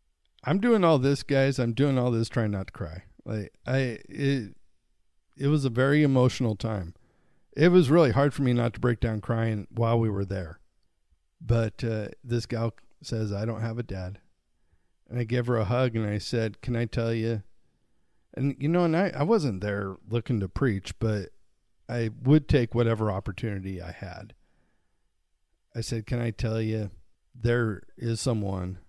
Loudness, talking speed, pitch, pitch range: -27 LUFS, 185 wpm, 115 Hz, 100-125 Hz